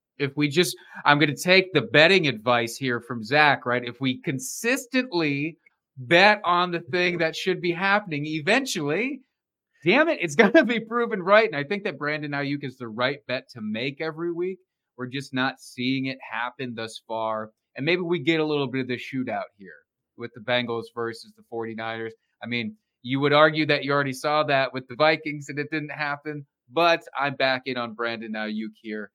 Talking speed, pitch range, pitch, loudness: 200 wpm, 125-170 Hz, 145 Hz, -24 LUFS